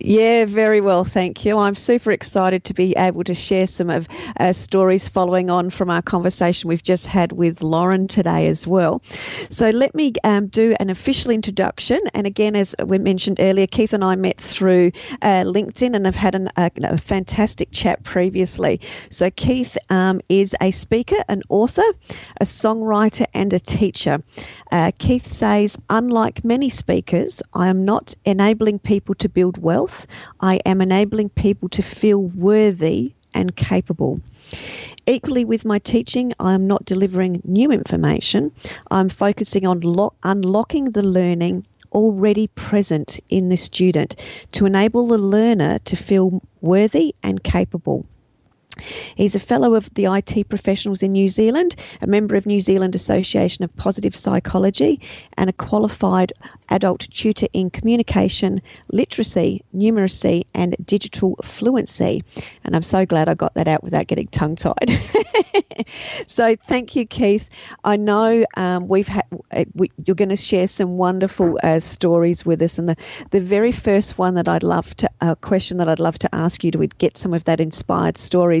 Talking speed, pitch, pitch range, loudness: 165 wpm, 195 Hz, 180-215 Hz, -18 LUFS